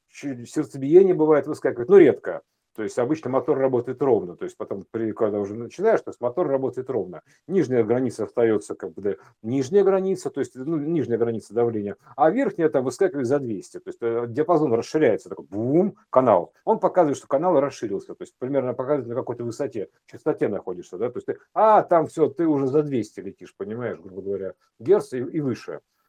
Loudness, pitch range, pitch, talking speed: -23 LUFS, 120-190 Hz, 145 Hz, 185 wpm